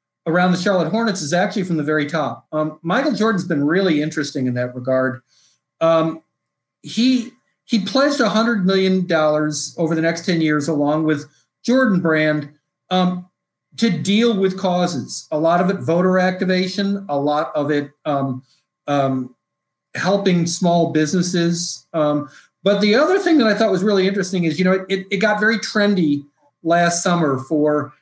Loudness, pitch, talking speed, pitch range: -18 LUFS, 170 Hz, 165 wpm, 150-195 Hz